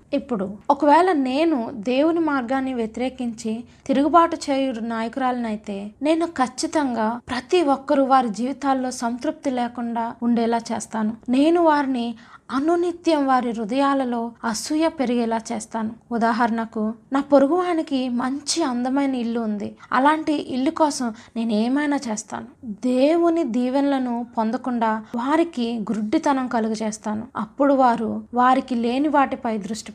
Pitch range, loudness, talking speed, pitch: 230-280 Hz, -22 LUFS, 110 wpm, 255 Hz